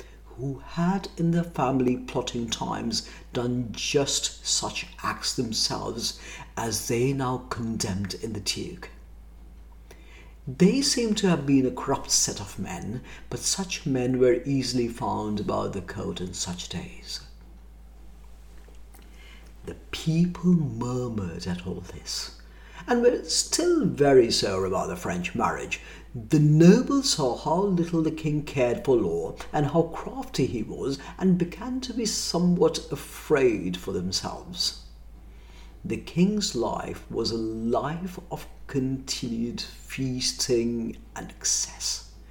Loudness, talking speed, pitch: -26 LUFS, 130 wpm, 125 Hz